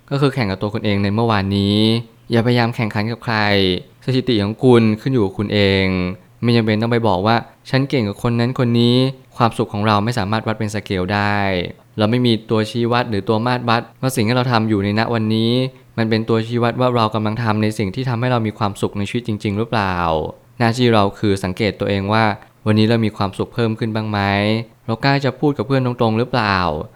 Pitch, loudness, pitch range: 110 Hz, -18 LUFS, 105-120 Hz